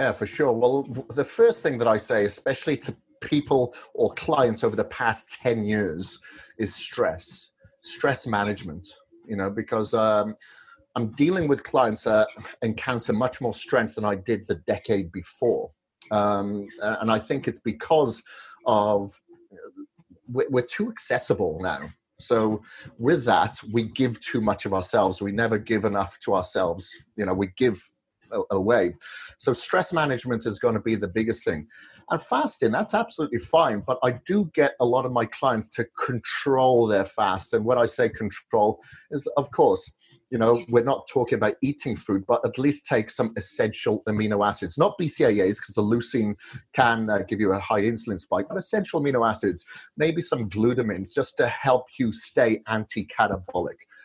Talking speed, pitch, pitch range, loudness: 165 wpm, 115 Hz, 105-140 Hz, -25 LUFS